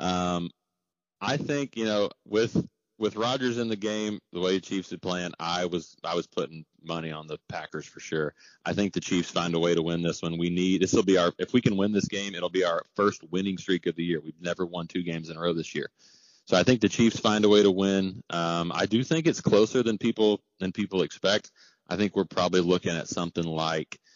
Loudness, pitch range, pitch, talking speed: -27 LUFS, 85-105 Hz, 90 Hz, 245 wpm